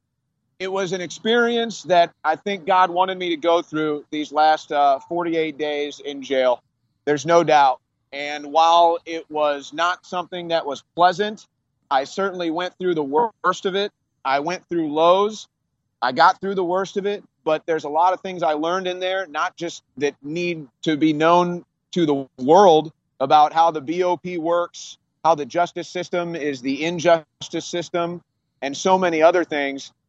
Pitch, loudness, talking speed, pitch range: 165 Hz, -21 LUFS, 175 wpm, 150-180 Hz